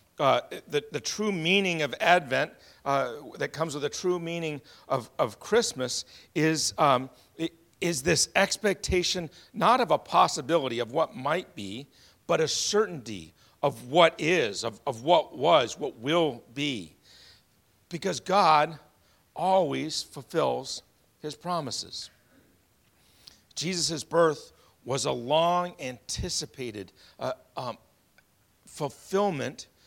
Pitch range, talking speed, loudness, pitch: 125-175 Hz, 115 wpm, -27 LUFS, 150 Hz